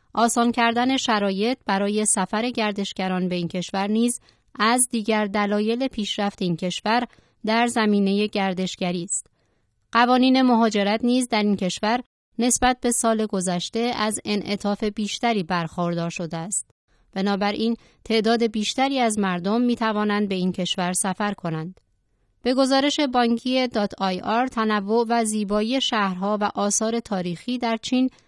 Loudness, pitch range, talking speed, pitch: -22 LUFS, 195-235 Hz, 130 wpm, 215 Hz